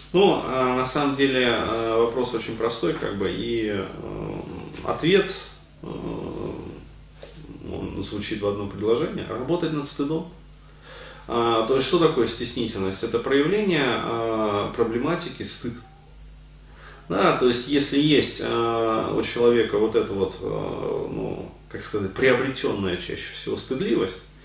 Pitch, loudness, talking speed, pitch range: 115 Hz, -24 LUFS, 135 wpm, 110-140 Hz